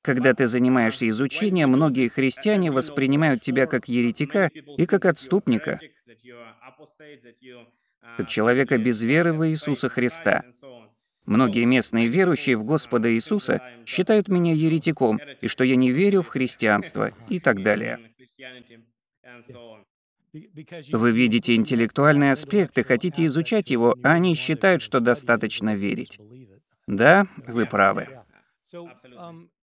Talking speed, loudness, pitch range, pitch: 115 wpm, -21 LUFS, 120-165 Hz, 130 Hz